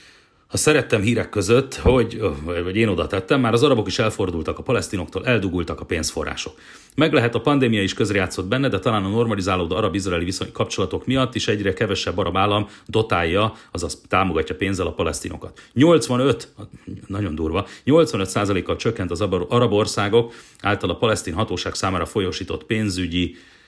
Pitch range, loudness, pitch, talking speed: 95-120 Hz, -21 LUFS, 105 Hz, 150 wpm